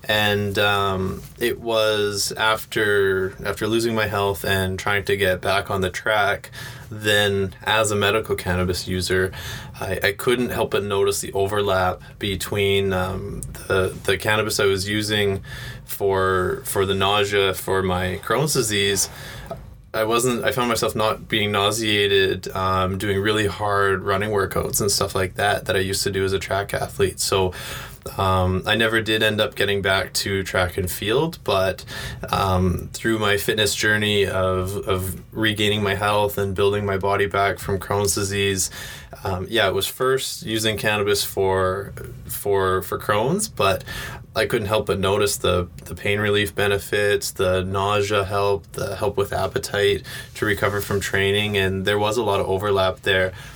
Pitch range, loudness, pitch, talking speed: 95-110 Hz, -21 LUFS, 100 Hz, 165 wpm